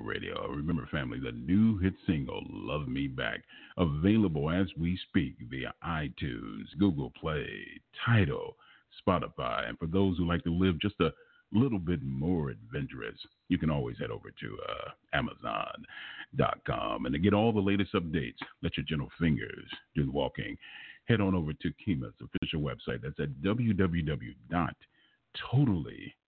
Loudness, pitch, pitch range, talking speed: -32 LUFS, 95 Hz, 85-105 Hz, 150 wpm